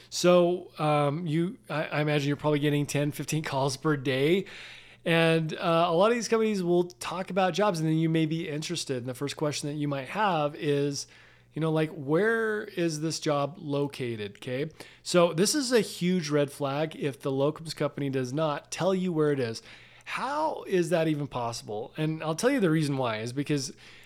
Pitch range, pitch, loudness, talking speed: 145-175 Hz, 155 Hz, -28 LUFS, 200 wpm